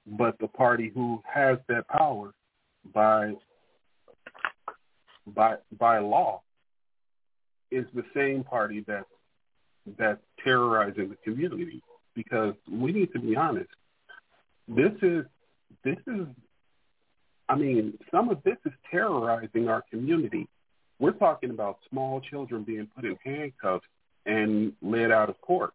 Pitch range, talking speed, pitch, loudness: 110-155 Hz, 125 wpm, 120 Hz, -28 LUFS